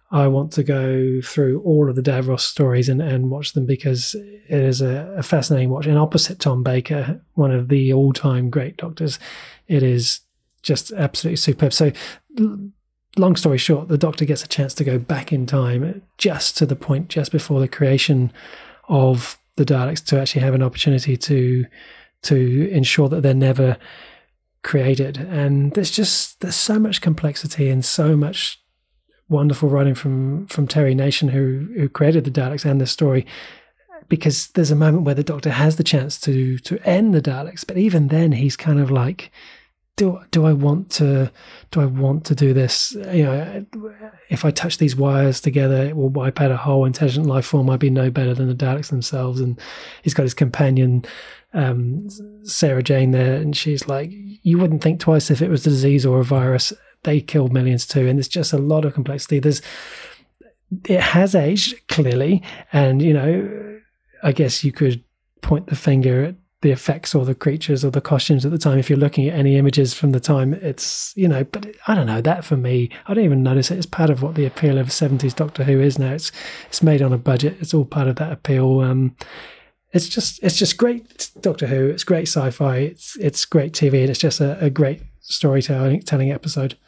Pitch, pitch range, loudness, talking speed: 145 Hz, 135-160 Hz, -18 LUFS, 200 wpm